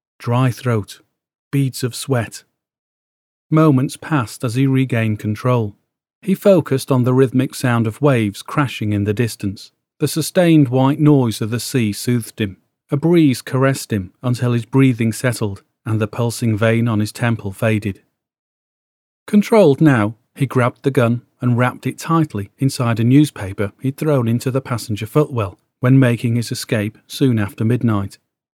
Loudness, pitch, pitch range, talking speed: -17 LUFS, 125 Hz, 110-135 Hz, 155 wpm